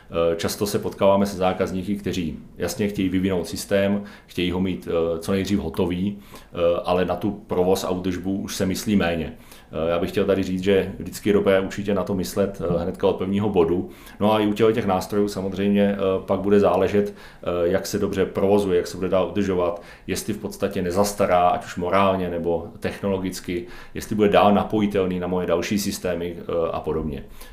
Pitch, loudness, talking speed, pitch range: 95 Hz, -23 LUFS, 175 wpm, 90-100 Hz